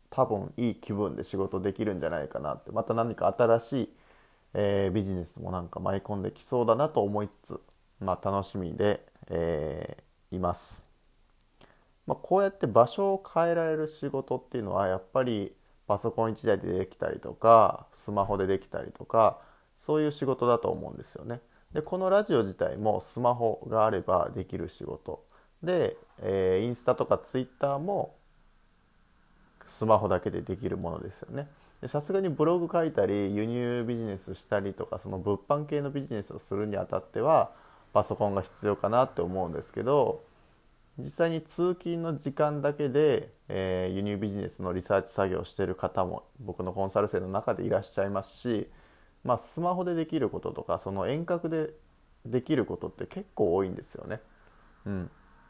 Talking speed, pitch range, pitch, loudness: 355 characters per minute, 100-150 Hz, 115 Hz, -30 LUFS